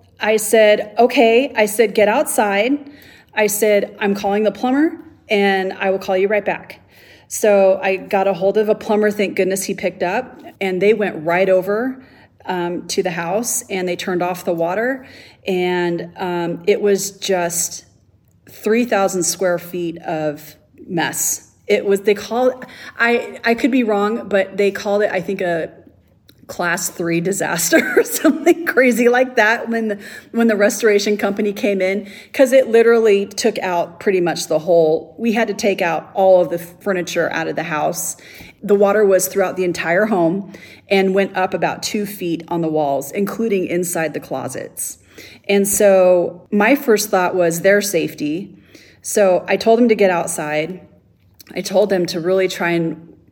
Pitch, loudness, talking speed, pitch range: 195 Hz, -17 LUFS, 175 wpm, 175-215 Hz